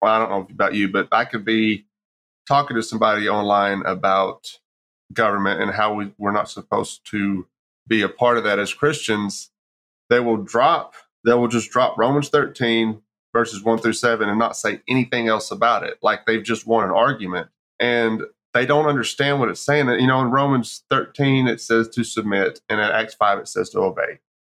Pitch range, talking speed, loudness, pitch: 105-120 Hz, 195 wpm, -20 LUFS, 110 Hz